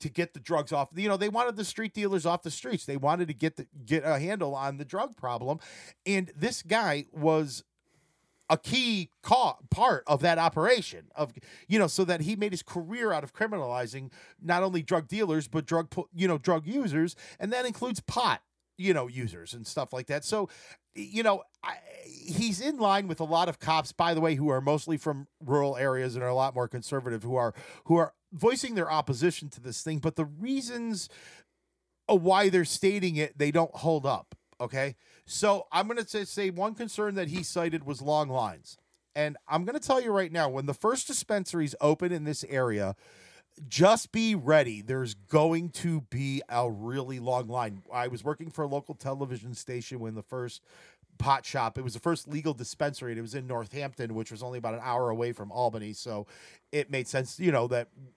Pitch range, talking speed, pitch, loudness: 130-185 Hz, 205 wpm, 155 Hz, -30 LUFS